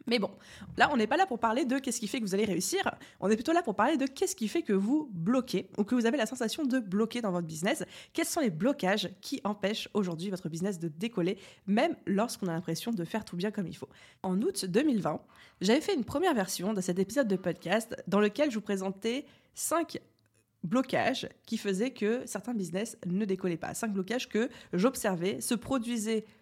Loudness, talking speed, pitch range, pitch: -31 LUFS, 220 wpm, 190-245 Hz, 215 Hz